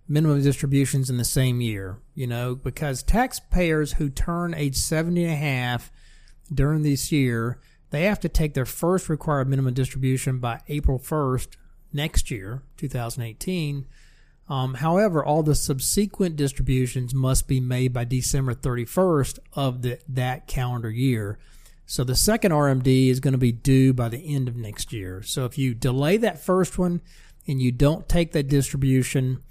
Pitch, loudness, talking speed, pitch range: 135 Hz, -24 LUFS, 165 wpm, 125-150 Hz